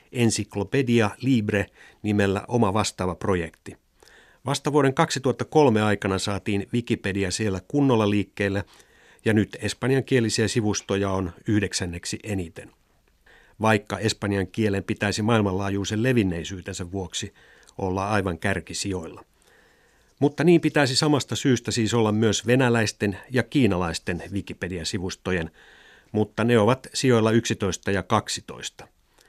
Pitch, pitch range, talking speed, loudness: 105 Hz, 95-120 Hz, 105 wpm, -24 LUFS